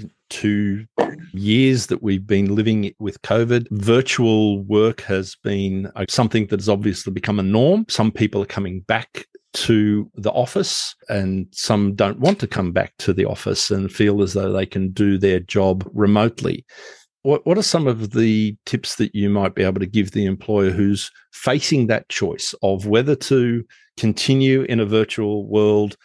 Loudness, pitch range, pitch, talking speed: -19 LUFS, 100-115 Hz, 105 Hz, 170 wpm